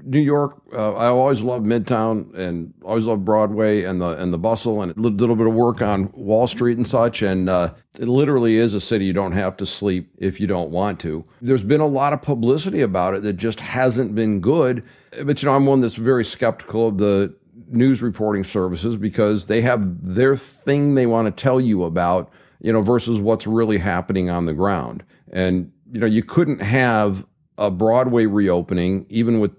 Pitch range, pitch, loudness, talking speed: 100-125 Hz, 110 Hz, -19 LUFS, 205 wpm